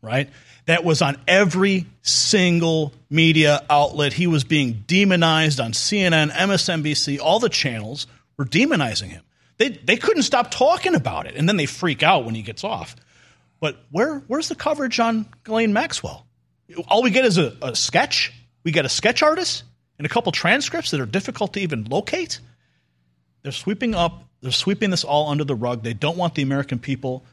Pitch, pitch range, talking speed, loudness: 160 Hz, 135-200 Hz, 180 wpm, -20 LUFS